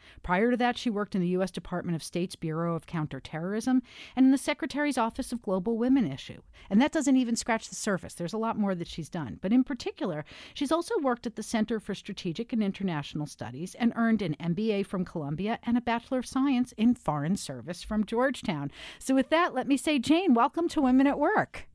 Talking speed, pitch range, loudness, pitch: 220 wpm, 175-255 Hz, -29 LUFS, 225 Hz